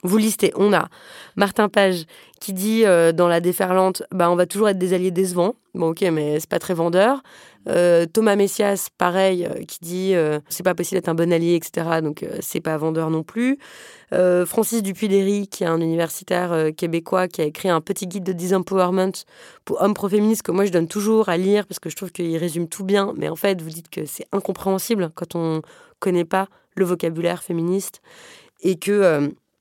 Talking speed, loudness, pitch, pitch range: 205 wpm, -21 LUFS, 185 Hz, 170-200 Hz